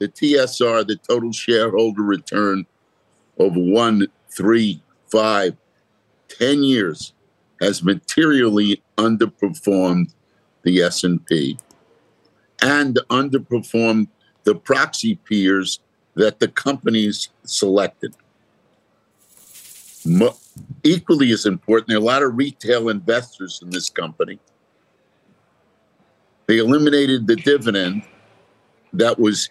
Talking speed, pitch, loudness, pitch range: 95 wpm, 110 Hz, -18 LUFS, 100-120 Hz